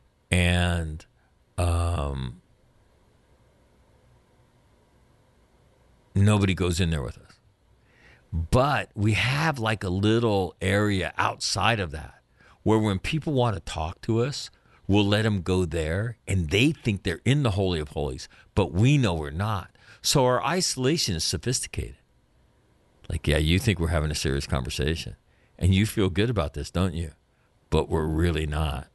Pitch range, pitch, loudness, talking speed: 80-110 Hz, 95 Hz, -25 LUFS, 145 wpm